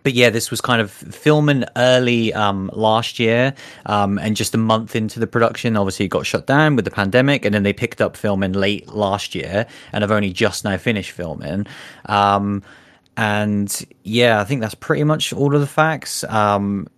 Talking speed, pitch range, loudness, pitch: 200 wpm, 100-125 Hz, -18 LUFS, 110 Hz